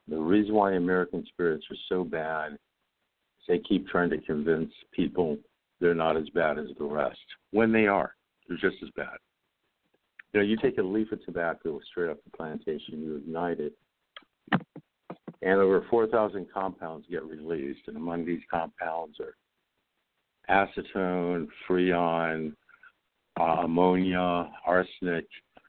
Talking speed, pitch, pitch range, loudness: 140 wpm, 90 Hz, 85-100 Hz, -29 LUFS